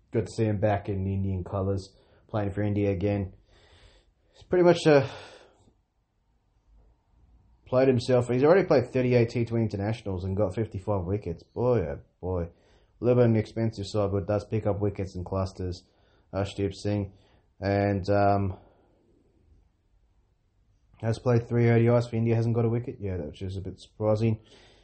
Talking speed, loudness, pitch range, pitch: 160 wpm, -27 LUFS, 95-115 Hz, 100 Hz